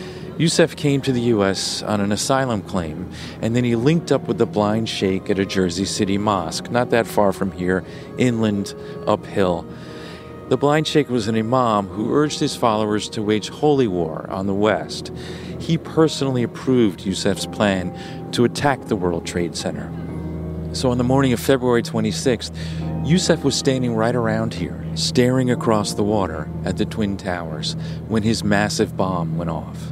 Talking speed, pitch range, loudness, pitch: 170 wpm, 90-125 Hz, -20 LUFS, 105 Hz